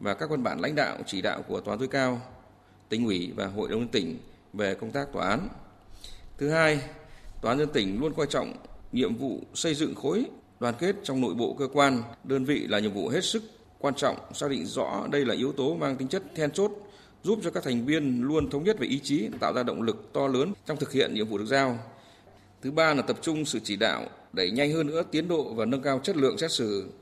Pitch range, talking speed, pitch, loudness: 120-160 Hz, 245 wpm, 135 Hz, -28 LUFS